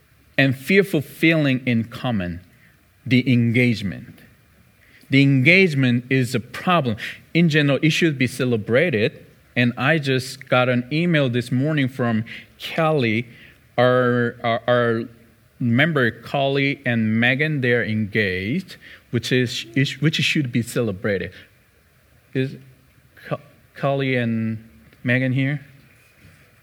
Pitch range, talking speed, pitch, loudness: 120-140 Hz, 110 wpm, 125 Hz, -20 LUFS